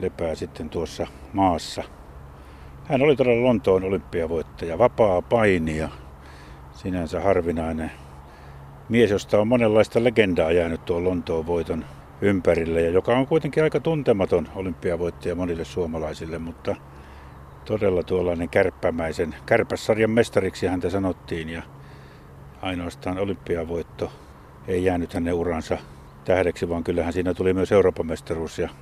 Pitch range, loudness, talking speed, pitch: 70-95 Hz, -23 LUFS, 115 wpm, 85 Hz